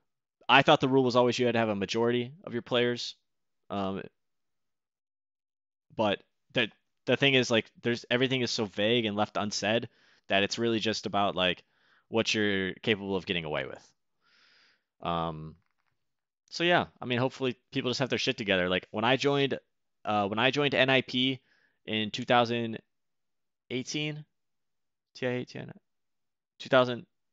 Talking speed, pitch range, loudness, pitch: 160 wpm, 105-130 Hz, -28 LUFS, 120 Hz